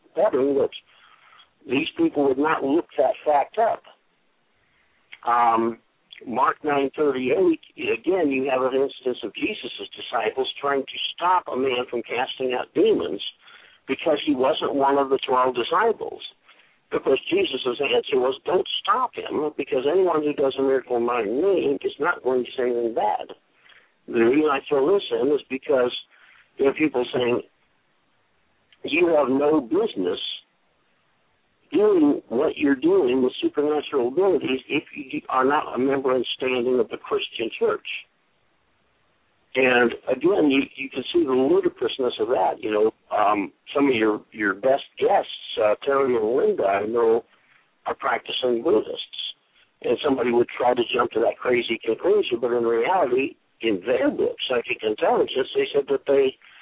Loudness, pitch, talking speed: -23 LUFS, 225 Hz, 155 wpm